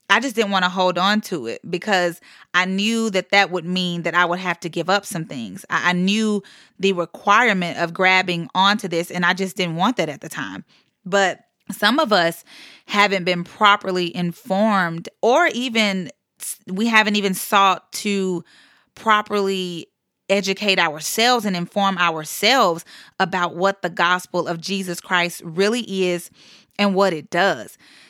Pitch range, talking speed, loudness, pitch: 175-205 Hz, 160 wpm, -19 LUFS, 190 Hz